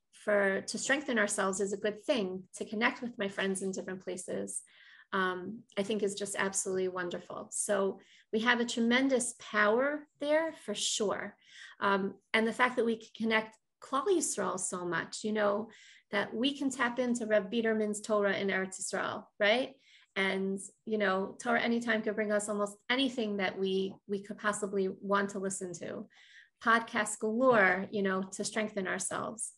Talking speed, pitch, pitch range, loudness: 170 wpm, 210 Hz, 195-230 Hz, -32 LUFS